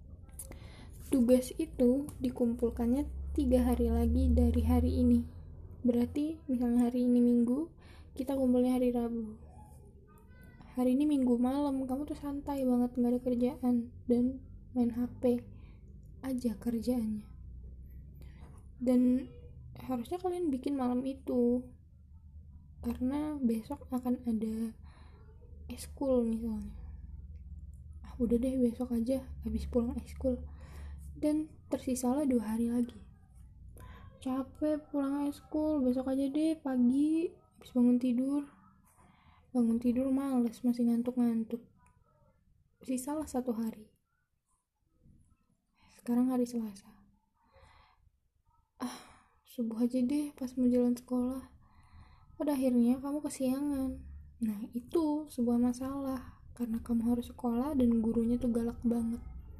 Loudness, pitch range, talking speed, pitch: -32 LUFS, 225-260 Hz, 110 wpm, 245 Hz